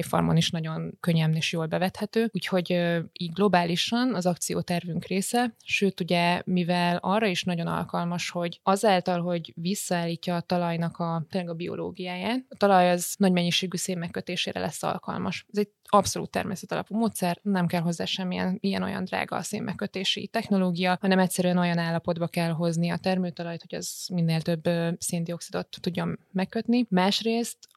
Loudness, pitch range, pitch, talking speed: -27 LUFS, 170-195 Hz, 180 Hz, 155 wpm